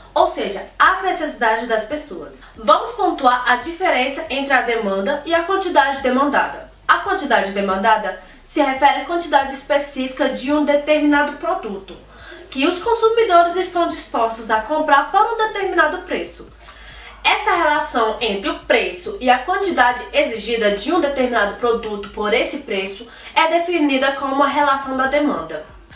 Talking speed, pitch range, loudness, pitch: 145 wpm, 245-335 Hz, -18 LUFS, 285 Hz